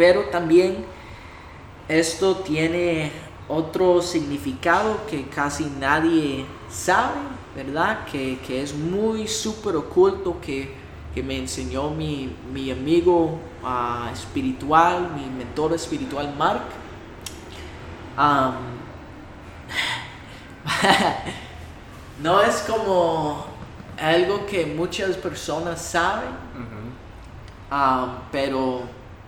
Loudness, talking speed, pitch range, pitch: -23 LUFS, 85 wpm, 130-175 Hz, 150 Hz